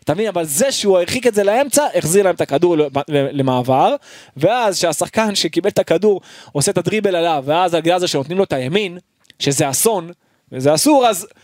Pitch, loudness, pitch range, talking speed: 180 Hz, -16 LUFS, 155-210 Hz, 190 wpm